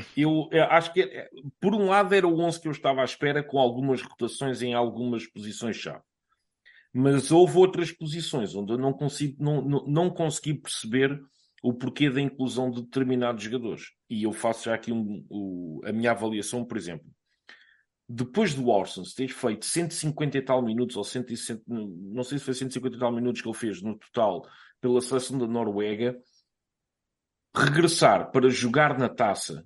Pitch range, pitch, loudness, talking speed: 120-145 Hz, 130 Hz, -26 LUFS, 175 wpm